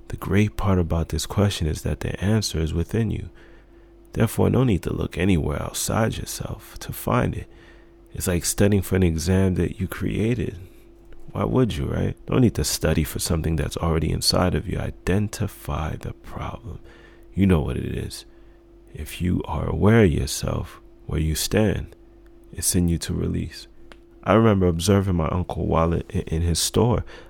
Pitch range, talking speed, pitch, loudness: 80-100 Hz, 175 wpm, 90 Hz, -23 LUFS